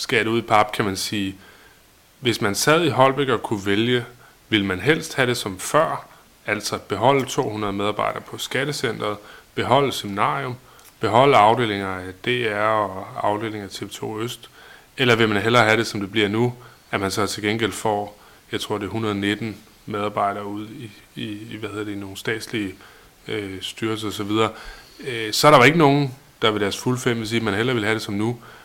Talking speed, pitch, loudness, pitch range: 195 wpm, 110 Hz, -21 LUFS, 105-120 Hz